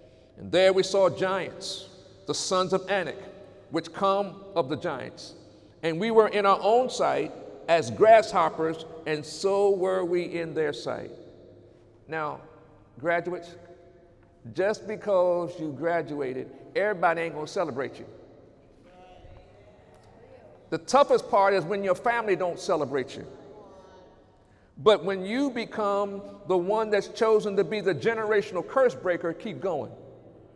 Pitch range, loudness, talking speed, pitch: 165-200 Hz, -26 LUFS, 130 wpm, 185 Hz